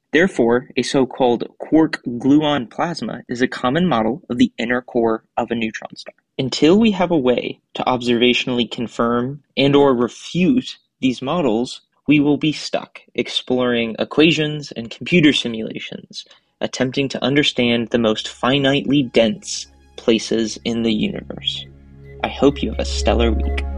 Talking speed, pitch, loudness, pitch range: 145 wpm, 125 Hz, -18 LUFS, 115-140 Hz